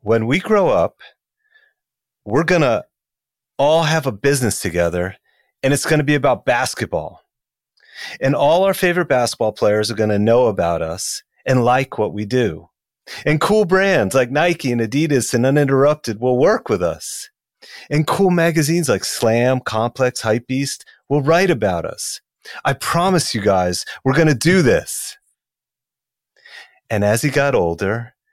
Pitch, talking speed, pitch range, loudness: 135 Hz, 155 wpm, 110-165 Hz, -17 LUFS